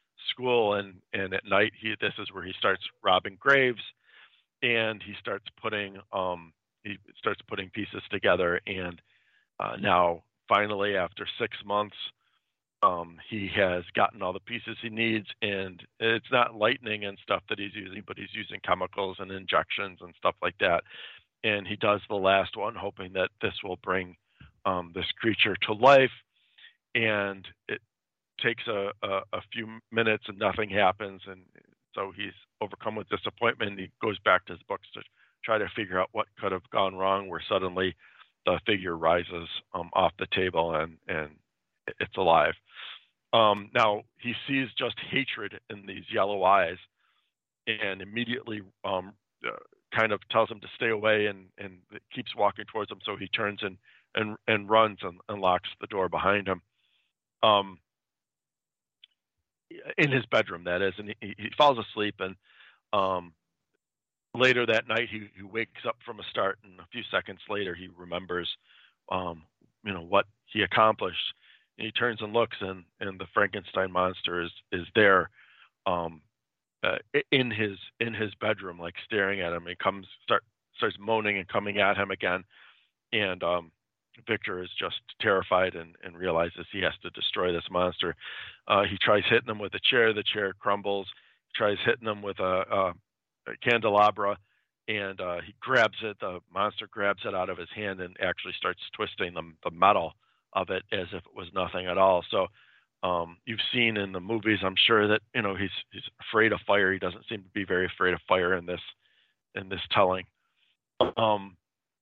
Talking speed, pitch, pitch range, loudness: 175 wpm, 100 Hz, 90-110 Hz, -28 LUFS